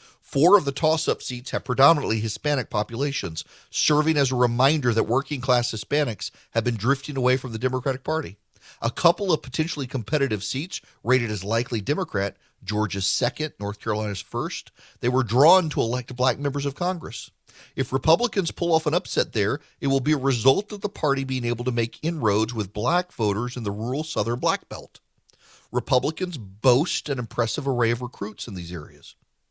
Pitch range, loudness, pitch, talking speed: 115-145 Hz, -24 LUFS, 130 Hz, 175 wpm